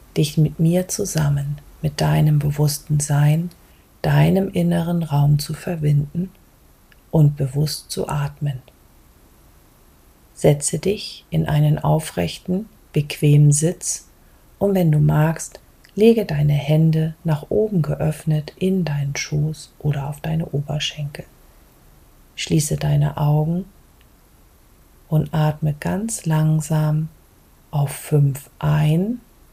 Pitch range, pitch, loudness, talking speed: 145-165 Hz, 155 Hz, -20 LUFS, 105 wpm